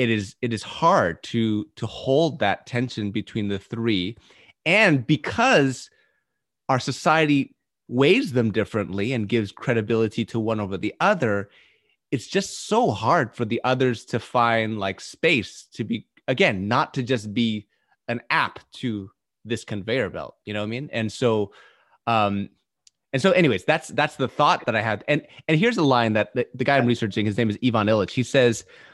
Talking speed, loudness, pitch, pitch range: 180 wpm, -23 LUFS, 115 Hz, 110-130 Hz